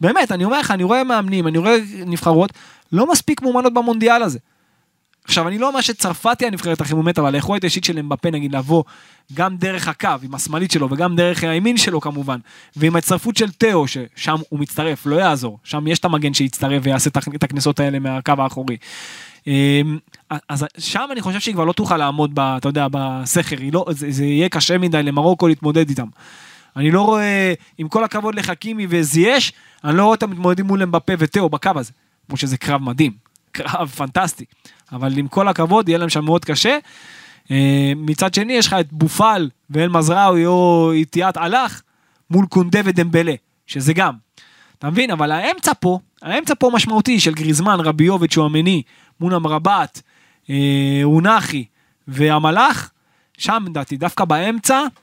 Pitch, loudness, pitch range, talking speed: 165 Hz, -17 LUFS, 145-195 Hz, 170 wpm